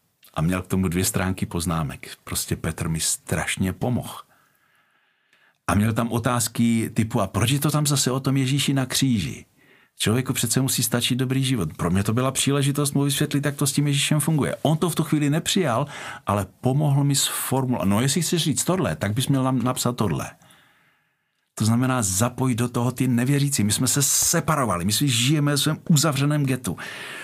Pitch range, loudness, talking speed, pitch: 110-140 Hz, -22 LUFS, 190 wpm, 130 Hz